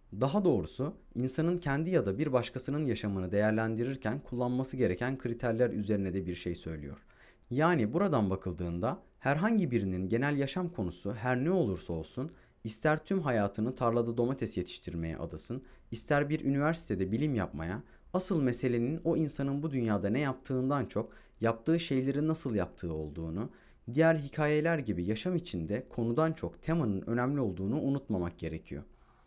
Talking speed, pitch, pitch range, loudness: 140 wpm, 120 Hz, 100-145 Hz, -32 LUFS